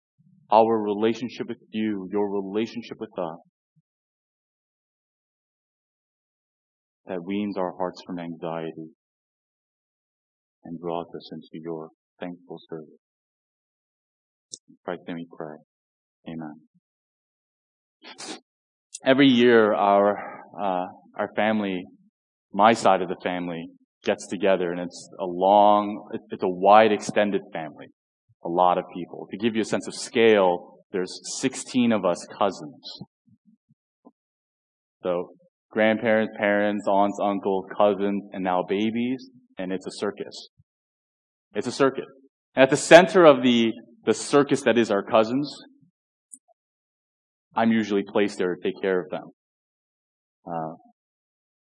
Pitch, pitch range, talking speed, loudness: 100 Hz, 90-115 Hz, 115 wpm, -23 LUFS